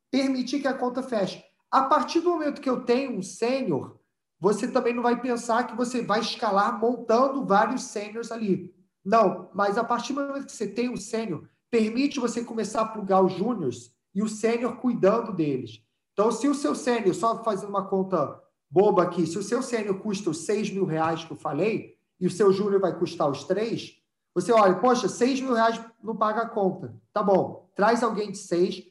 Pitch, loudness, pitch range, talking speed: 215 Hz, -26 LUFS, 185-240 Hz, 200 wpm